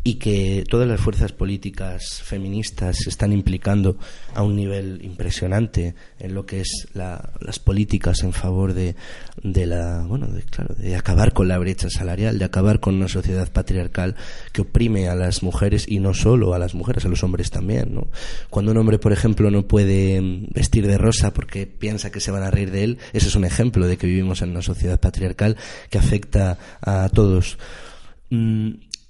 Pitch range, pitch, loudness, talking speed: 90-105 Hz, 95 Hz, -21 LUFS, 190 wpm